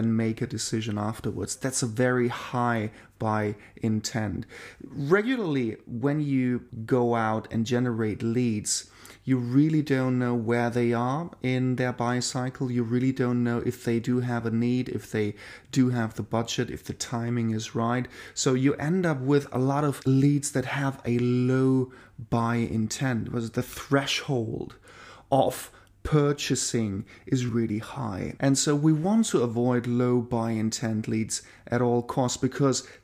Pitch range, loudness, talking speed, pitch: 115-130 Hz, -27 LUFS, 160 wpm, 120 Hz